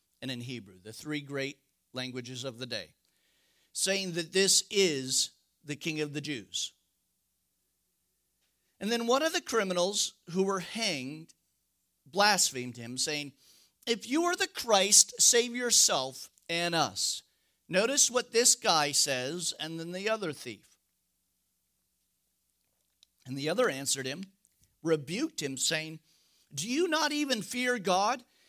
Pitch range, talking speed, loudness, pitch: 135-225 Hz, 135 wpm, -28 LUFS, 165 Hz